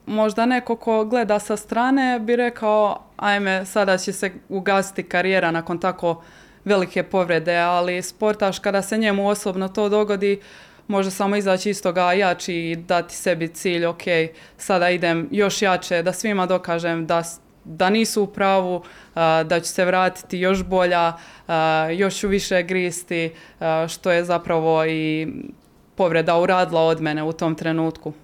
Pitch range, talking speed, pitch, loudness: 170-200 Hz, 155 wpm, 185 Hz, -21 LUFS